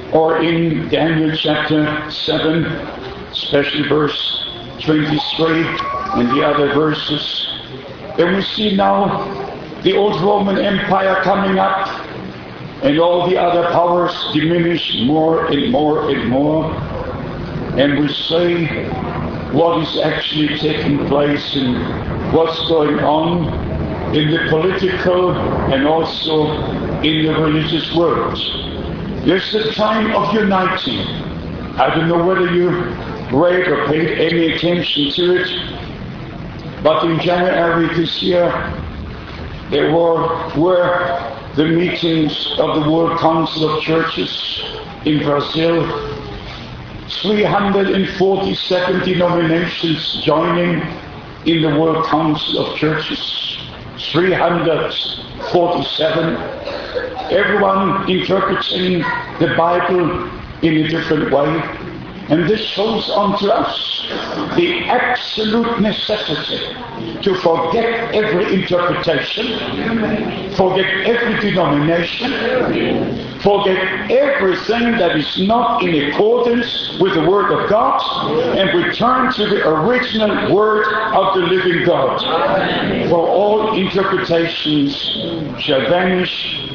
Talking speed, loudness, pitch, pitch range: 105 wpm, -16 LUFS, 170 Hz, 155-195 Hz